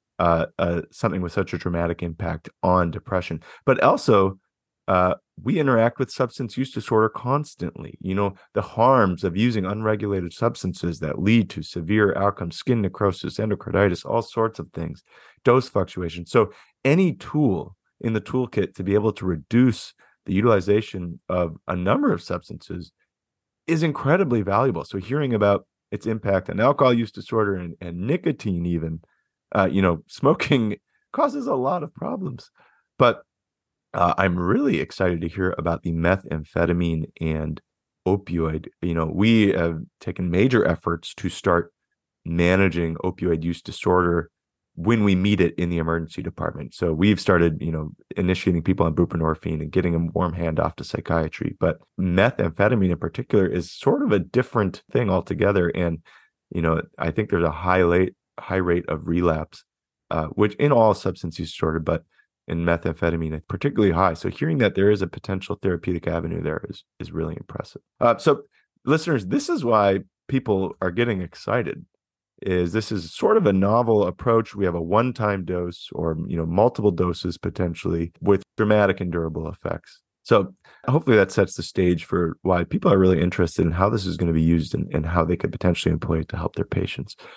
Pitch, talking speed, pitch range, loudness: 95 Hz, 170 wpm, 85-105 Hz, -23 LUFS